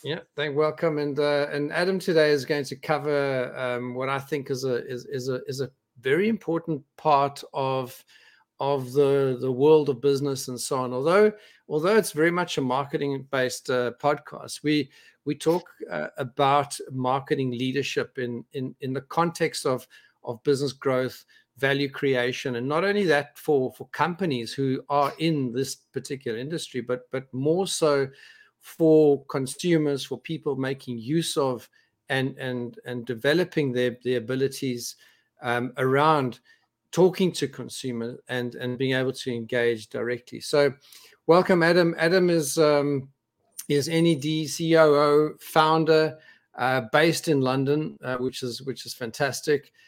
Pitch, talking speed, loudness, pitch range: 140 Hz, 155 wpm, -25 LUFS, 130-155 Hz